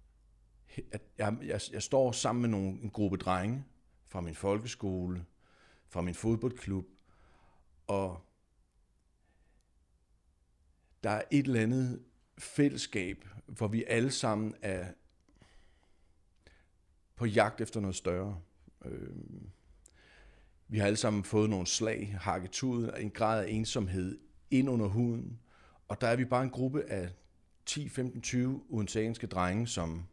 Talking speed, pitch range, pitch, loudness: 120 wpm, 85-115 Hz, 100 Hz, -34 LUFS